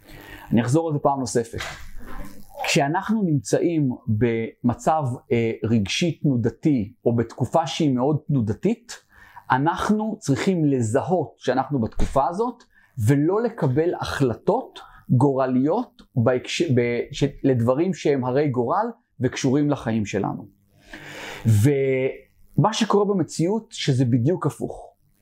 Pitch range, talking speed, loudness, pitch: 125-165 Hz, 100 wpm, -22 LUFS, 140 Hz